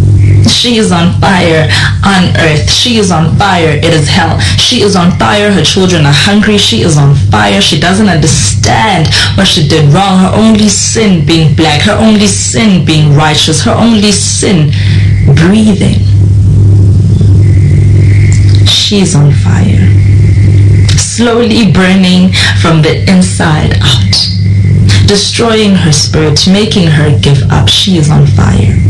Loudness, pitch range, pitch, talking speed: -5 LUFS, 100-165 Hz, 125 Hz, 140 wpm